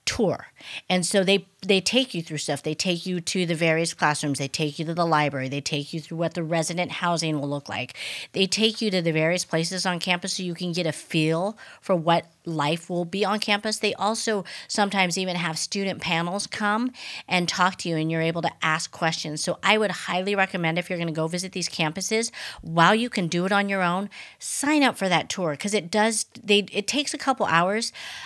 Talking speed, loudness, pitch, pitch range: 230 wpm, -24 LUFS, 180 Hz, 165-205 Hz